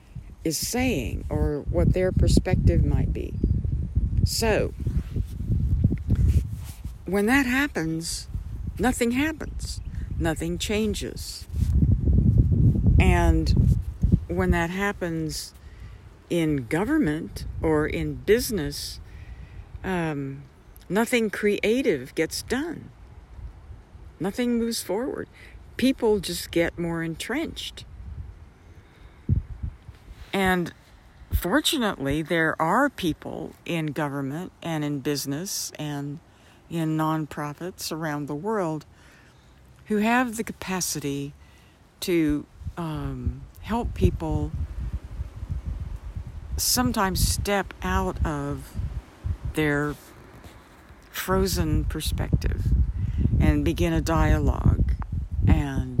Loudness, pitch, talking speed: -26 LUFS, 145 Hz, 80 wpm